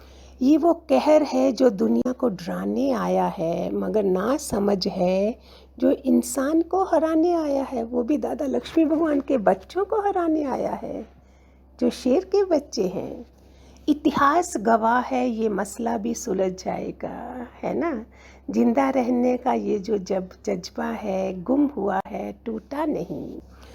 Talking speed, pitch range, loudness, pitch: 150 wpm, 200-295 Hz, -23 LUFS, 250 Hz